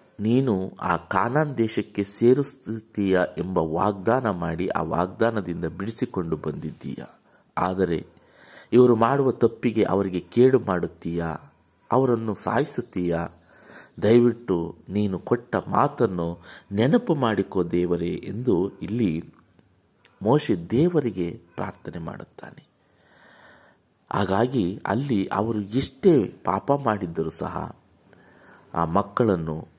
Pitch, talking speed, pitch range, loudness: 105 Hz, 85 wpm, 90-120 Hz, -24 LUFS